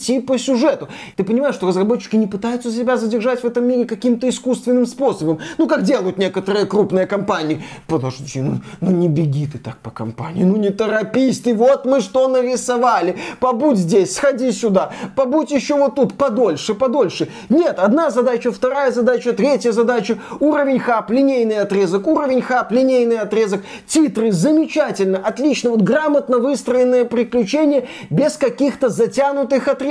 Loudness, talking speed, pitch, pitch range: -17 LUFS, 150 wpm, 240 Hz, 205-265 Hz